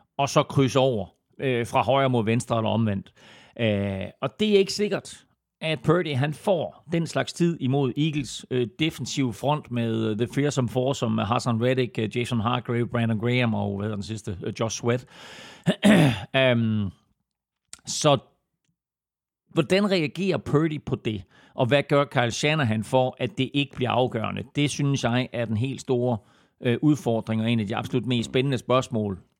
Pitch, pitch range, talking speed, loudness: 125 Hz, 115-140 Hz, 175 wpm, -25 LUFS